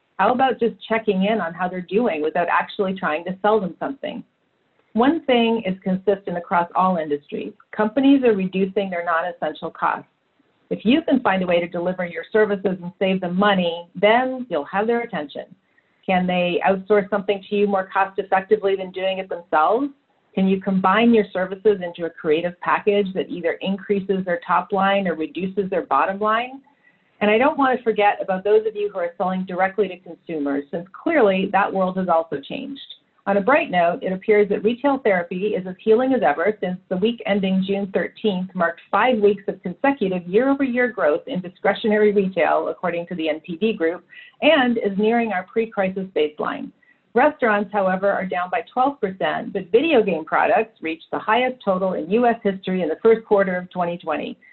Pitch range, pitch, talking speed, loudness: 180-220 Hz, 195 Hz, 190 wpm, -21 LUFS